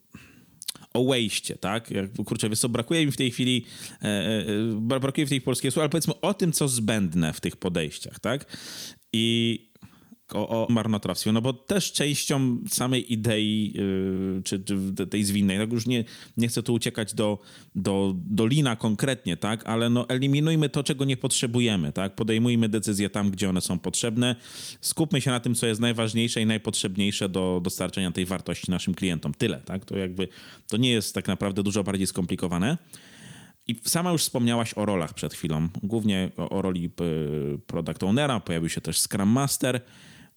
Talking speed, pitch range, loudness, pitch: 175 wpm, 95-125 Hz, -26 LUFS, 110 Hz